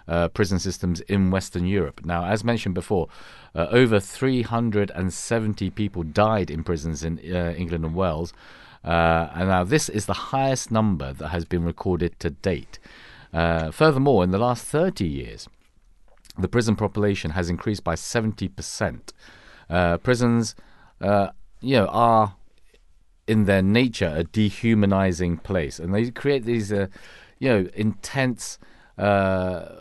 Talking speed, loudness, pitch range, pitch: 145 wpm, -23 LUFS, 85-110 Hz, 95 Hz